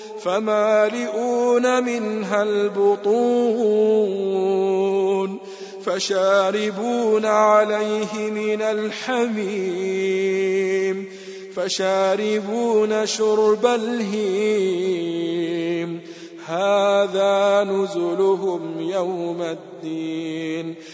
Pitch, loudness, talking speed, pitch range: 195 Hz, -21 LUFS, 40 wpm, 190-215 Hz